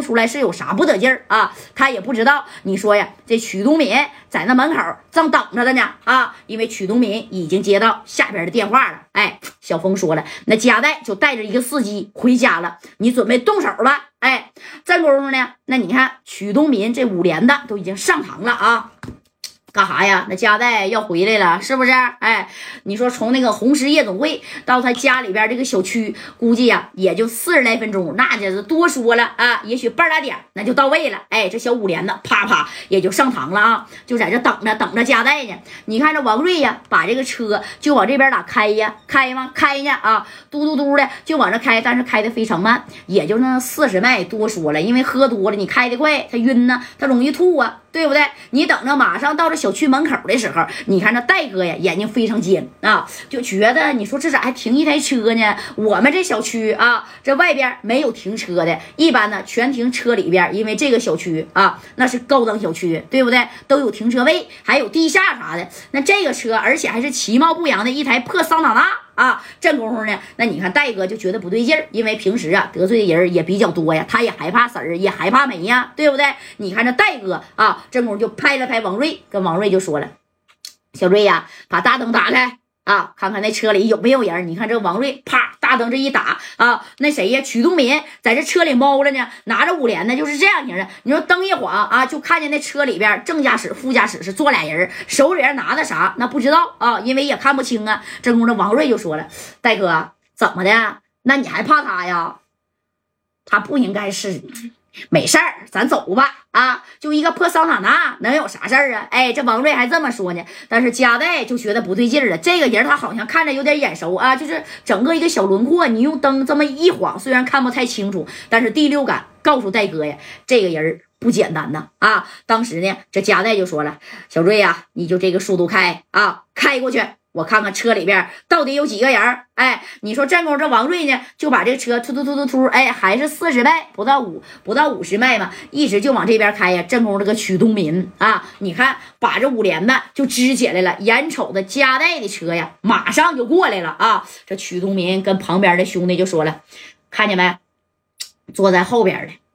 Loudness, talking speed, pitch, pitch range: -16 LUFS, 310 characters per minute, 240 Hz, 205-280 Hz